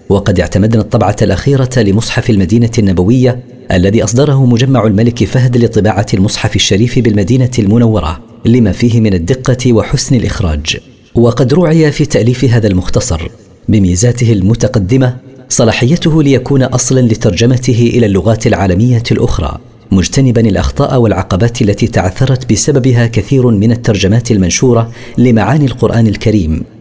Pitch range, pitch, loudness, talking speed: 105-125 Hz, 115 Hz, -10 LUFS, 115 wpm